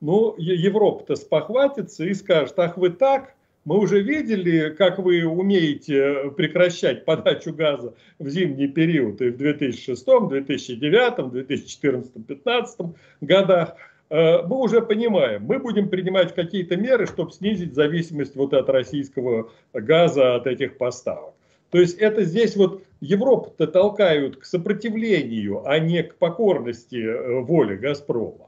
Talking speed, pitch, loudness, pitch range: 125 wpm, 170 Hz, -21 LUFS, 145-200 Hz